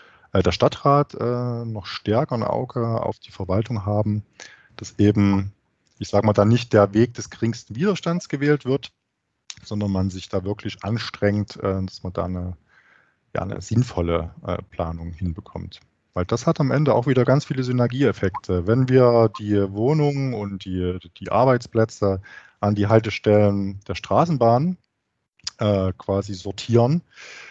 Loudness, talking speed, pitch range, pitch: -22 LUFS, 150 wpm, 100-120 Hz, 105 Hz